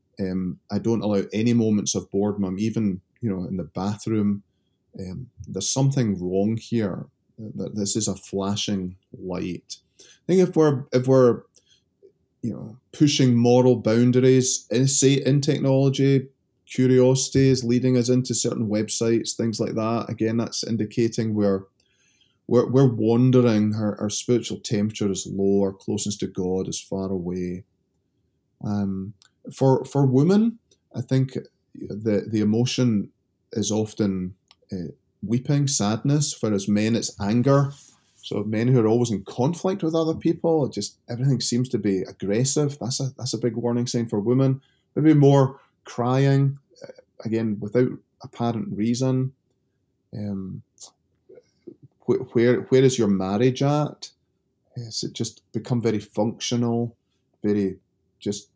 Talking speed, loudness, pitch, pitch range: 140 wpm, -23 LUFS, 115 Hz, 100-130 Hz